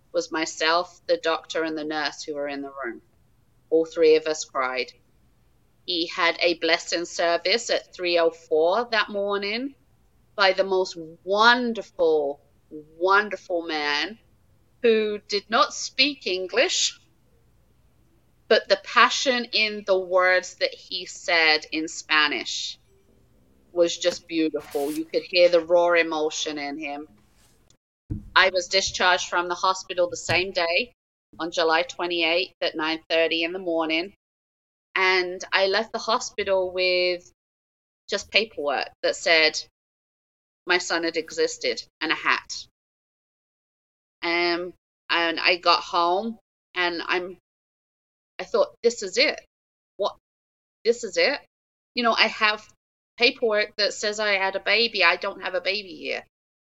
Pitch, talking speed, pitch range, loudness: 175 Hz, 135 wpm, 160-200 Hz, -23 LUFS